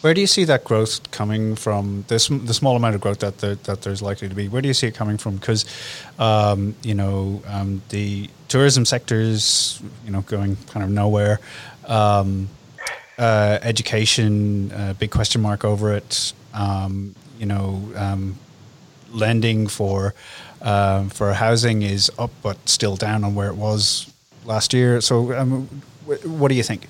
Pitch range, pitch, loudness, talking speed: 100-120 Hz, 110 Hz, -20 LUFS, 170 wpm